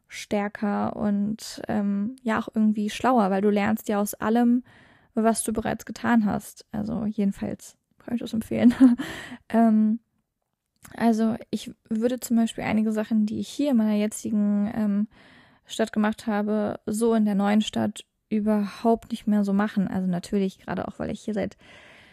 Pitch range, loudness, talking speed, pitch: 210-230 Hz, -25 LUFS, 165 wpm, 220 Hz